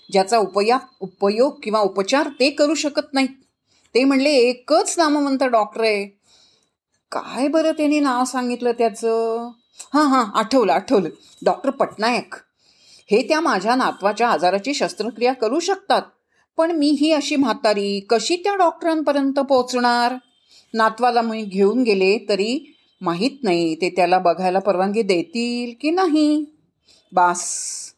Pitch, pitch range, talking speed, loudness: 245 Hz, 210-290 Hz, 130 wpm, -19 LUFS